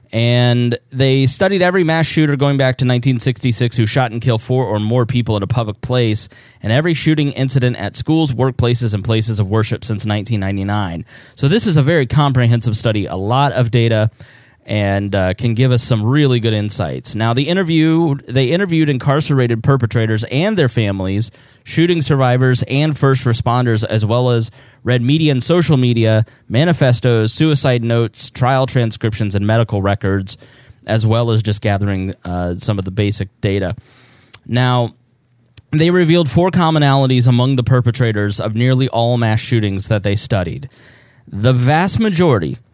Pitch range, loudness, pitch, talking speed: 110-135 Hz, -15 LUFS, 120 Hz, 165 wpm